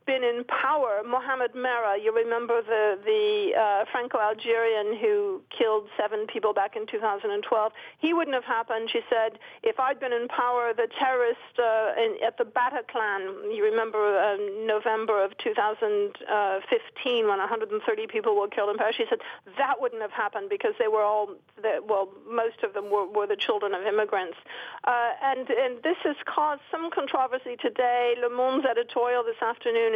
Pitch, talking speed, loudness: 240 Hz, 170 wpm, -27 LUFS